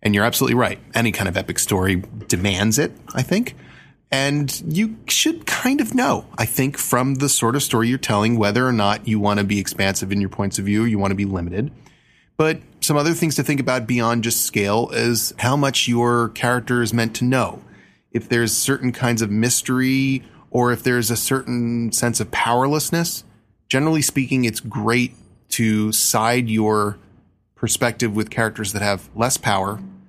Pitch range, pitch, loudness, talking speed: 110-130 Hz, 120 Hz, -19 LUFS, 185 wpm